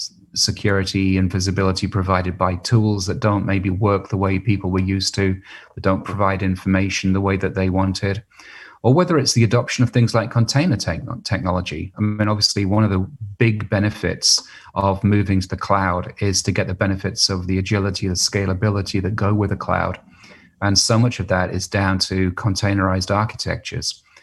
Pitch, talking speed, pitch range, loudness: 100 Hz, 185 wpm, 95-105 Hz, -19 LUFS